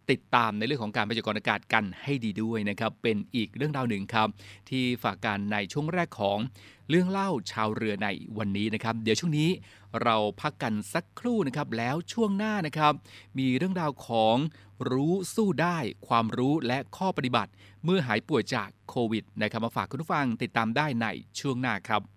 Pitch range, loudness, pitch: 105-150 Hz, -29 LUFS, 115 Hz